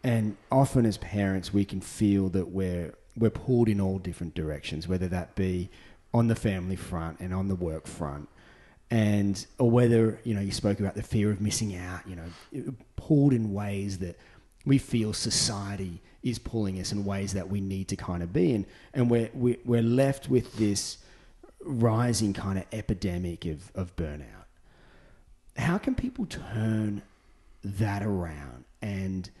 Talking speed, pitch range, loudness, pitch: 165 wpm, 90-115 Hz, -29 LUFS, 100 Hz